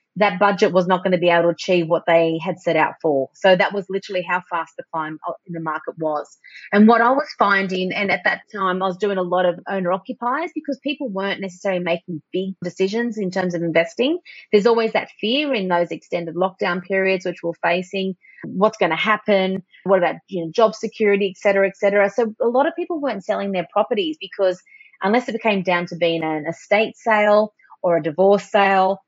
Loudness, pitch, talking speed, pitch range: -20 LUFS, 195 Hz, 215 wpm, 175-215 Hz